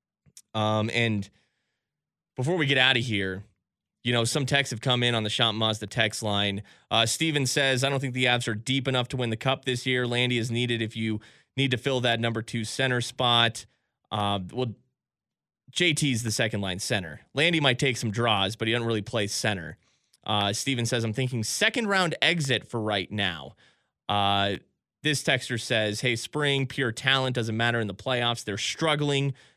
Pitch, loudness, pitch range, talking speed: 120 Hz, -26 LUFS, 110-135 Hz, 195 wpm